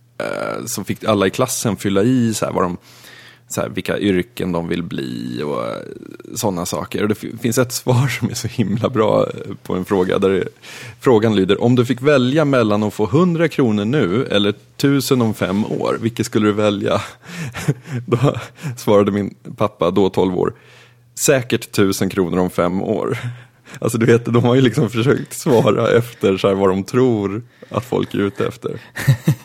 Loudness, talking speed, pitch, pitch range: -18 LUFS, 180 wpm, 115 Hz, 100-125 Hz